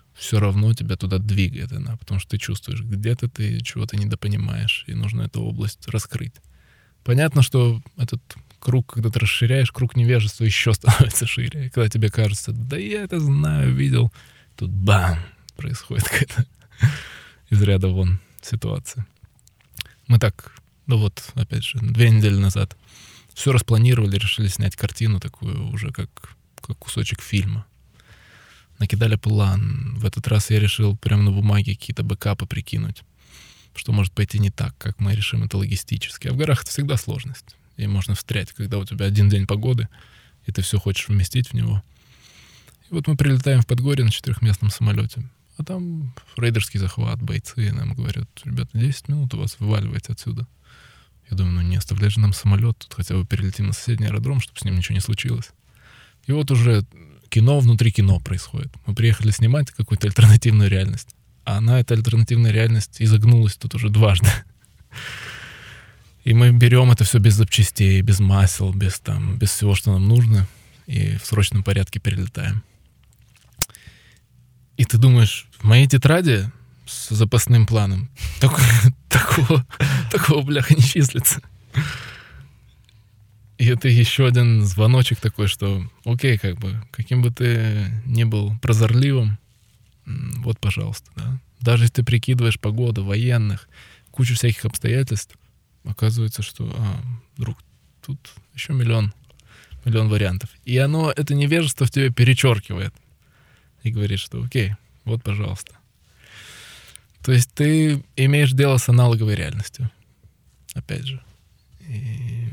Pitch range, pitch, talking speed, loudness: 105-125 Hz, 115 Hz, 145 wpm, -20 LUFS